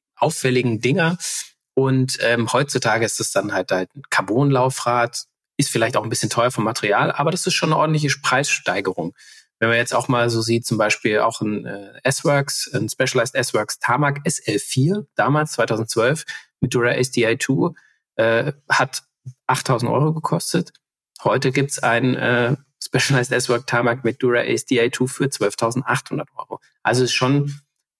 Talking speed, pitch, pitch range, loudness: 150 wpm, 125 Hz, 120-140 Hz, -20 LUFS